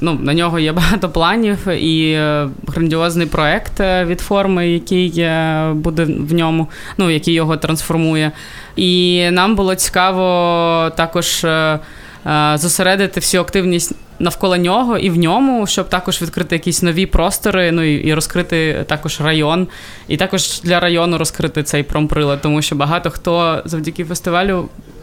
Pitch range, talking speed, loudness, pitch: 160-180 Hz, 135 wpm, -15 LUFS, 170 Hz